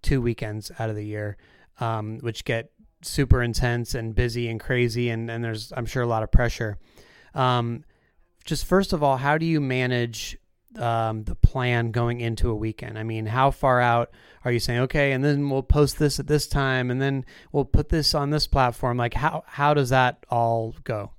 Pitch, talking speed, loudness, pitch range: 120 Hz, 205 wpm, -24 LUFS, 115-140 Hz